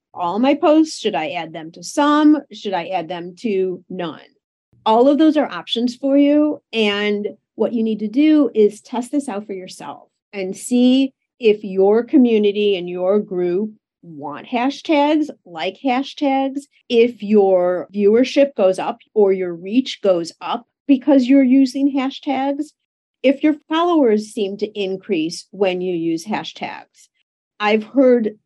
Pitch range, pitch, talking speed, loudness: 190-275 Hz, 220 Hz, 150 wpm, -18 LUFS